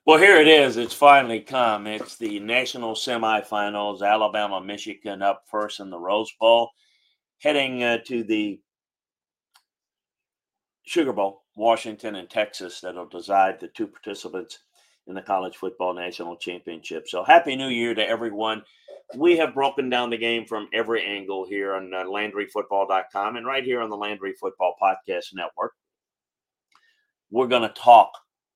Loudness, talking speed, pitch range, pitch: -22 LUFS, 145 wpm, 100-125 Hz, 110 Hz